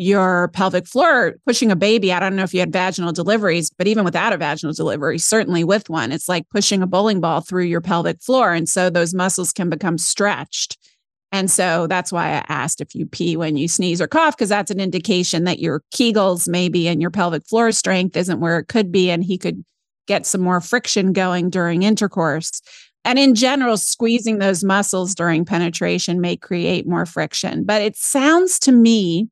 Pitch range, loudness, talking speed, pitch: 170-210 Hz, -18 LUFS, 205 wpm, 185 Hz